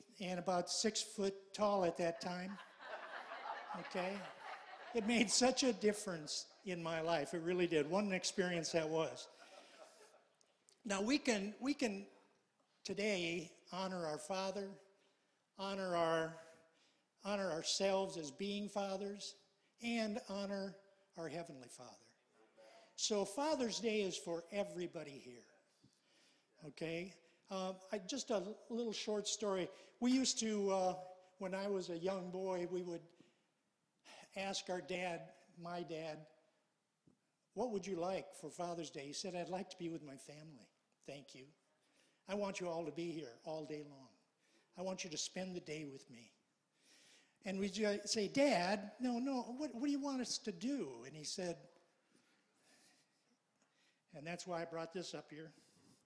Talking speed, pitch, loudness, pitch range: 150 wpm, 185 Hz, -41 LUFS, 170-205 Hz